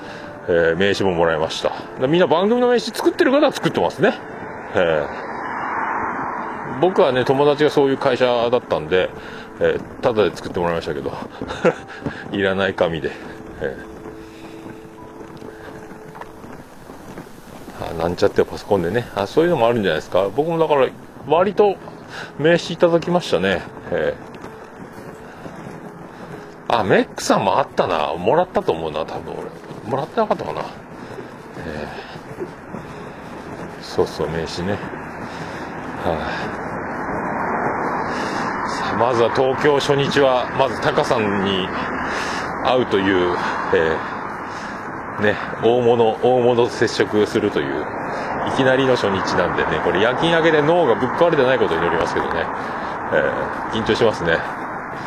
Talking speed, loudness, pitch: 270 characters per minute, -19 LUFS, 150 Hz